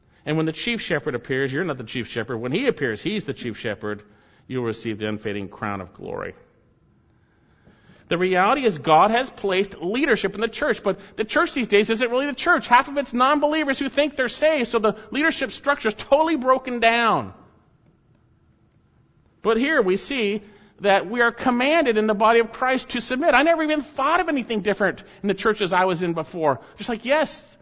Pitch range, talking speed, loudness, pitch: 180-260 Hz, 200 wpm, -22 LUFS, 220 Hz